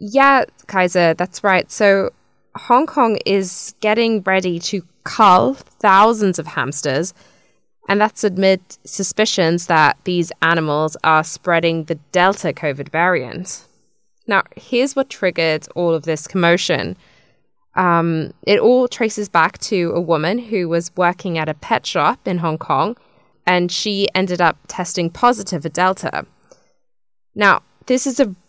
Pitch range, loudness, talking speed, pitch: 165-210 Hz, -17 LUFS, 140 wpm, 180 Hz